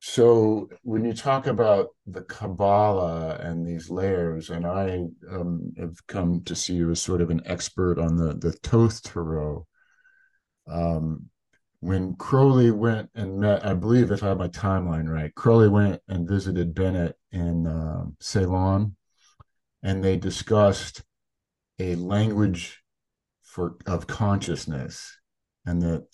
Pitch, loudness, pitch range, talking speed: 95 Hz, -24 LUFS, 85-105 Hz, 140 wpm